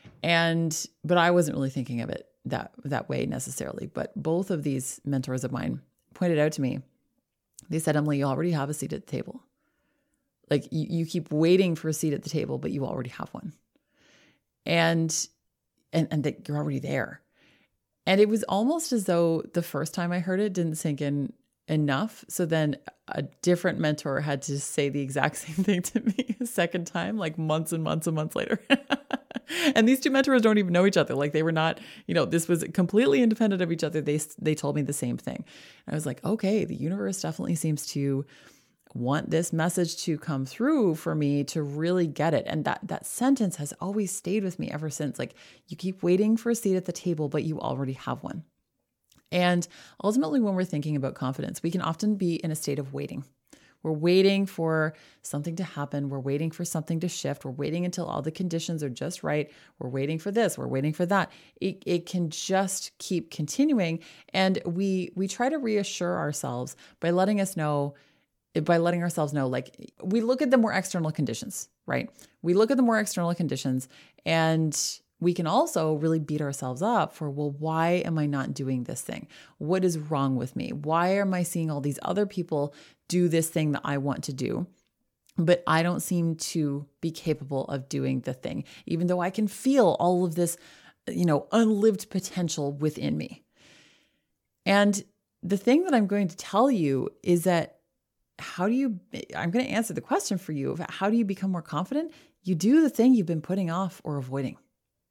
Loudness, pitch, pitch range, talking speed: -27 LUFS, 170 Hz, 150-190 Hz, 205 wpm